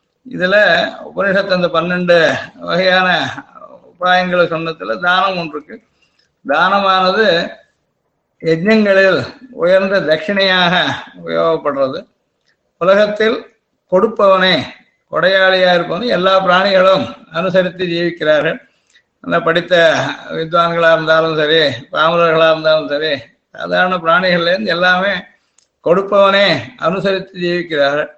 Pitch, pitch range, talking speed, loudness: 180 Hz, 165-195 Hz, 80 wpm, -13 LUFS